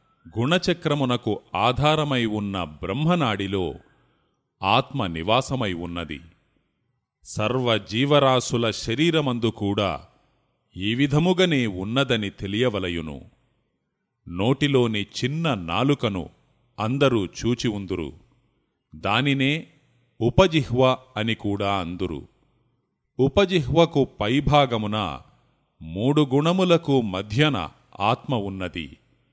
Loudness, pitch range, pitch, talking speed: -23 LUFS, 100-140 Hz, 120 Hz, 60 wpm